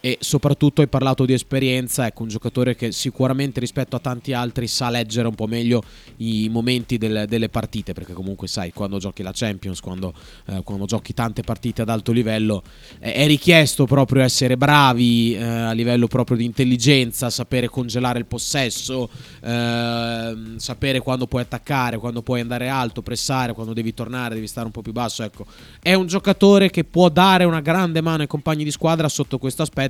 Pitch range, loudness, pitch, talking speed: 115-135 Hz, -20 LUFS, 120 Hz, 190 wpm